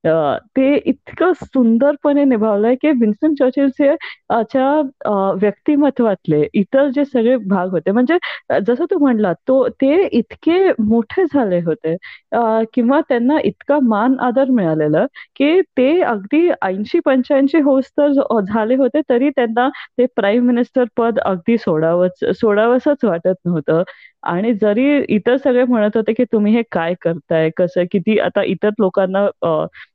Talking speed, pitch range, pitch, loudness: 130 wpm, 205-275 Hz, 240 Hz, -16 LUFS